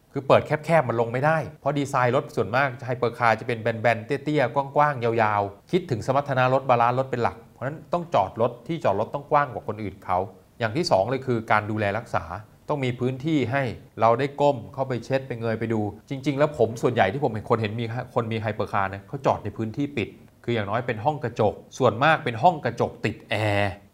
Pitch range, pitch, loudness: 110-140 Hz, 120 Hz, -24 LUFS